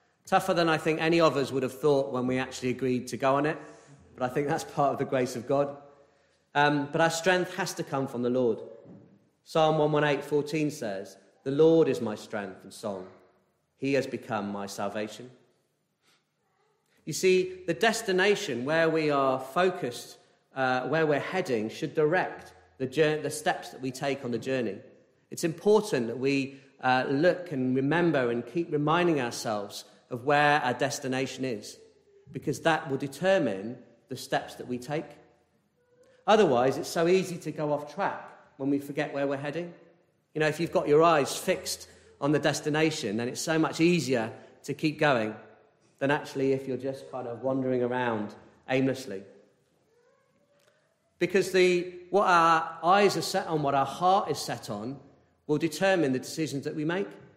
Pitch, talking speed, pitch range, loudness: 145 Hz, 175 wpm, 130-165 Hz, -28 LUFS